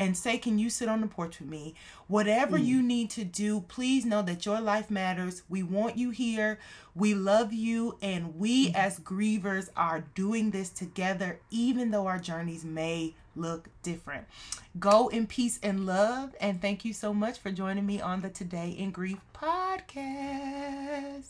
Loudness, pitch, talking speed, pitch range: -30 LUFS, 205 Hz, 175 wpm, 185-230 Hz